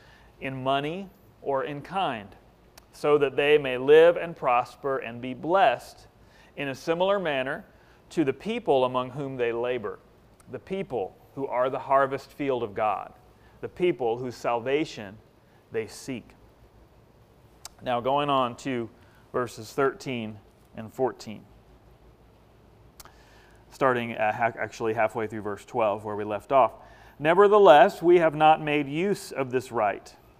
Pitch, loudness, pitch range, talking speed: 130 Hz, -25 LUFS, 120-155 Hz, 135 wpm